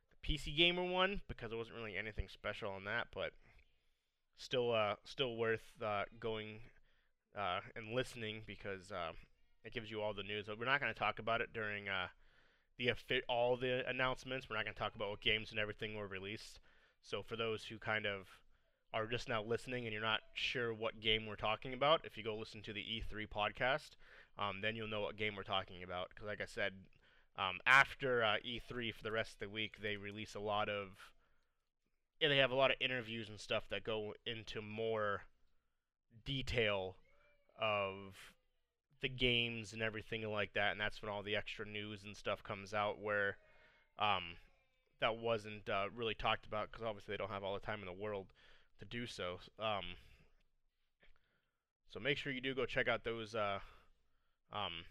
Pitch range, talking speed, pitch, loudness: 100-115 Hz, 195 wpm, 110 Hz, -40 LUFS